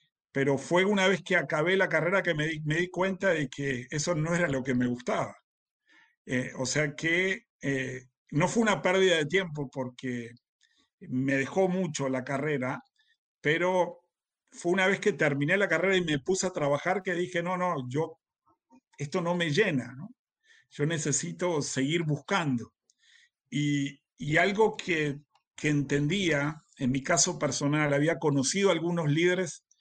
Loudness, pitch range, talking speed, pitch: -28 LUFS, 140-185 Hz, 165 wpm, 160 Hz